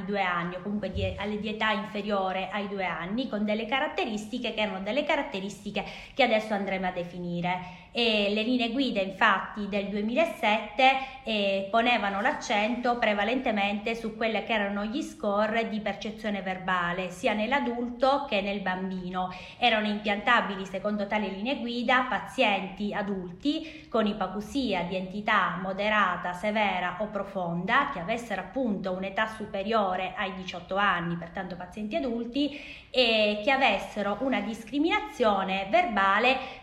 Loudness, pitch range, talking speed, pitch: -28 LUFS, 195-235 Hz, 135 wpm, 210 Hz